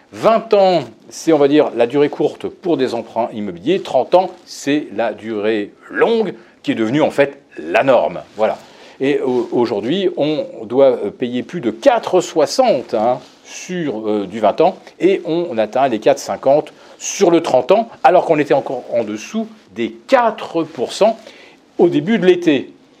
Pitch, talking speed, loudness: 160 Hz, 165 wpm, -16 LUFS